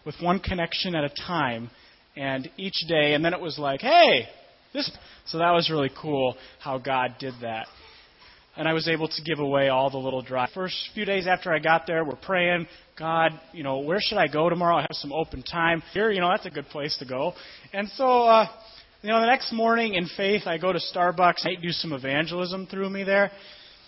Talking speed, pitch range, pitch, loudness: 220 wpm, 145-190 Hz, 165 Hz, -25 LUFS